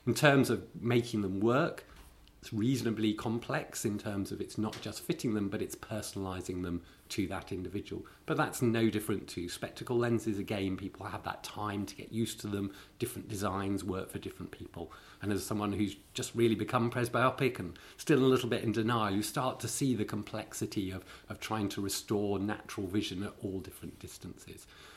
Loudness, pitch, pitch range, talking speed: -34 LUFS, 105 Hz, 100-120 Hz, 190 wpm